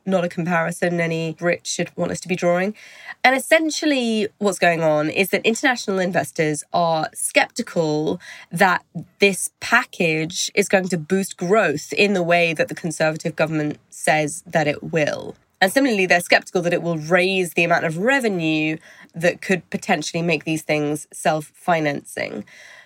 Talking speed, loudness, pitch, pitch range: 160 wpm, -20 LUFS, 175 Hz, 165-200 Hz